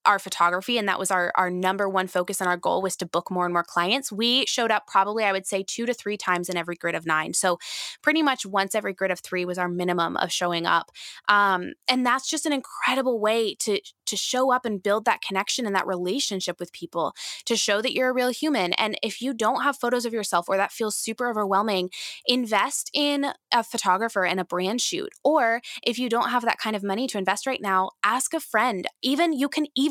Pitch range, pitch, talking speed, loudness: 185-250 Hz, 205 Hz, 235 wpm, -24 LUFS